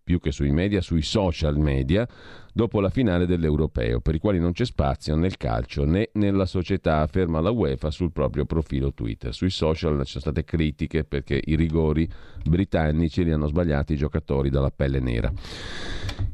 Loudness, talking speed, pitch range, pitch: -24 LUFS, 175 wpm, 75-95 Hz, 80 Hz